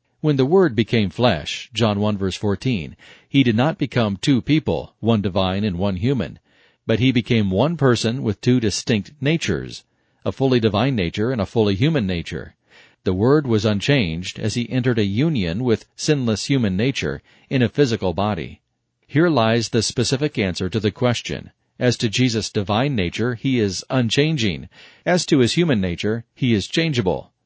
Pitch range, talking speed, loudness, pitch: 105-135 Hz, 175 wpm, -20 LUFS, 115 Hz